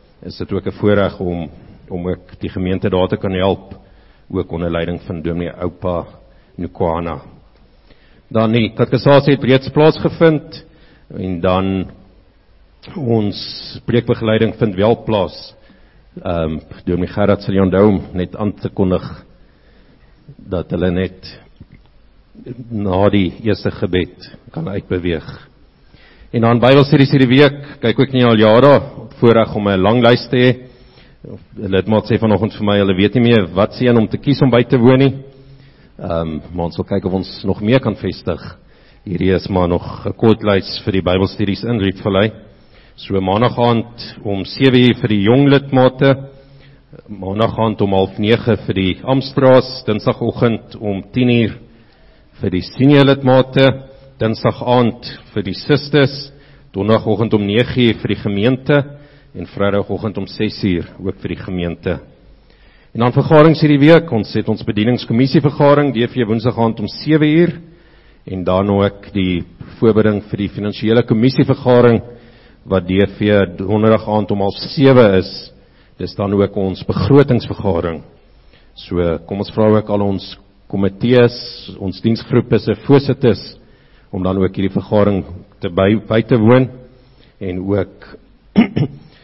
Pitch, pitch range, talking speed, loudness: 110 Hz, 95-125 Hz, 145 wpm, -15 LUFS